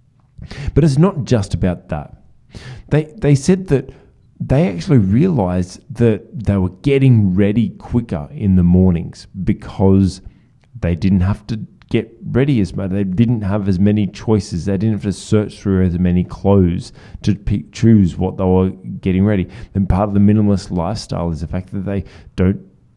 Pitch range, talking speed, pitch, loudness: 95-115 Hz, 175 wpm, 100 Hz, -16 LUFS